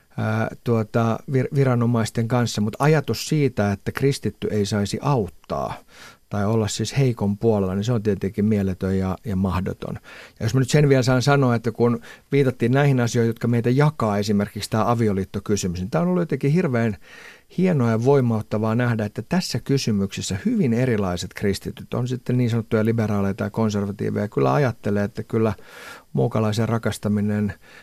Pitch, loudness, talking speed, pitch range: 115 Hz, -22 LUFS, 160 wpm, 105-125 Hz